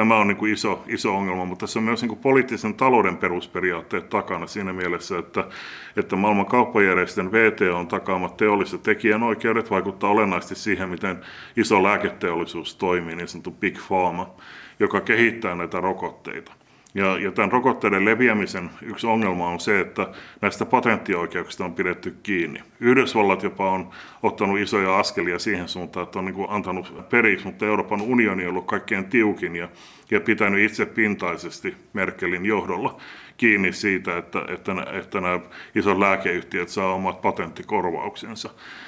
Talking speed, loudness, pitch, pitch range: 135 wpm, -22 LUFS, 95 Hz, 90-110 Hz